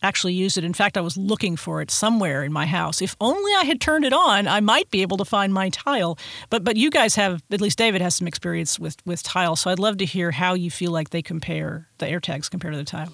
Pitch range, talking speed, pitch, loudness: 170-205 Hz, 275 wpm, 185 Hz, -21 LUFS